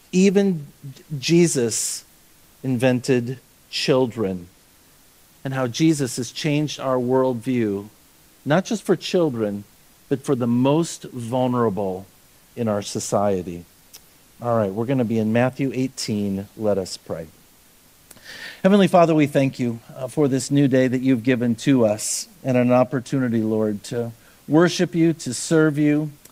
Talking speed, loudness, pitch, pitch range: 135 wpm, -21 LUFS, 130 Hz, 110-145 Hz